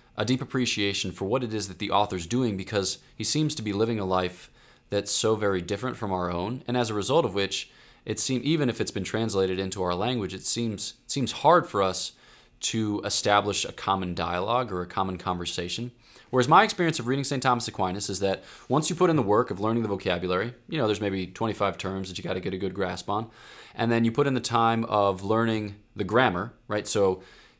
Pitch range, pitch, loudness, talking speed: 95-120 Hz, 105 Hz, -26 LUFS, 230 wpm